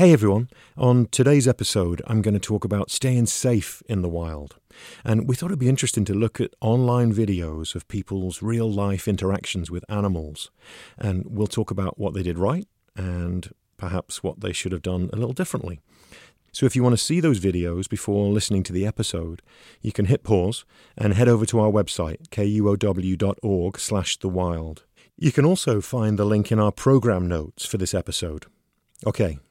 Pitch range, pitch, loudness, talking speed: 90-120 Hz, 105 Hz, -23 LUFS, 185 wpm